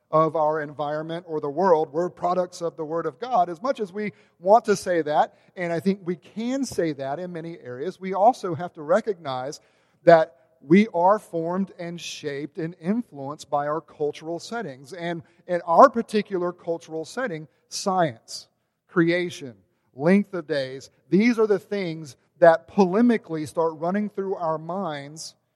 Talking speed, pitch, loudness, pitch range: 165 wpm, 170 Hz, -24 LUFS, 155-190 Hz